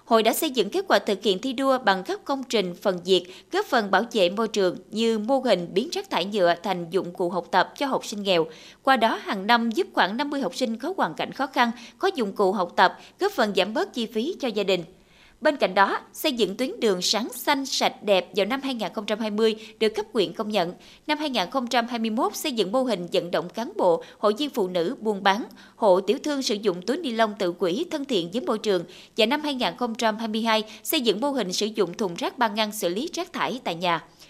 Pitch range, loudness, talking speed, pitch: 195-265 Hz, -24 LUFS, 235 wpm, 220 Hz